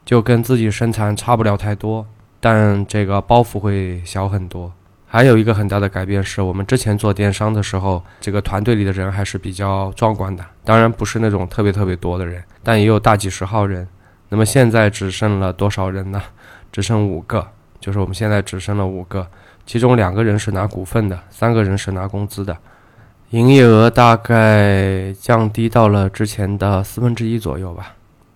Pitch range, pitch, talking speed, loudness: 95-110 Hz, 100 Hz, 290 characters per minute, -16 LUFS